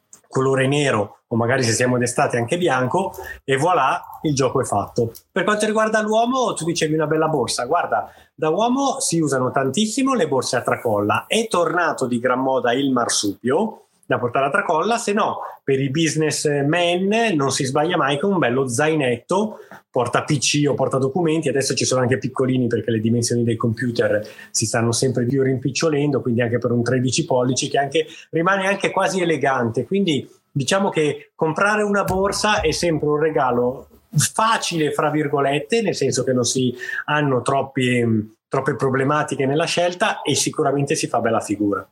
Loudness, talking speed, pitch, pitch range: -20 LUFS, 175 wpm, 145 Hz, 130-175 Hz